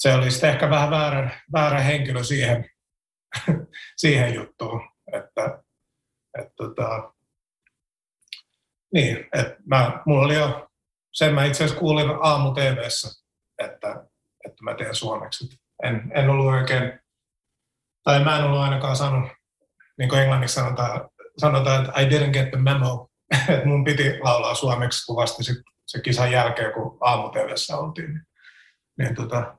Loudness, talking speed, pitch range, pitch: -22 LUFS, 135 wpm, 125-145 Hz, 135 Hz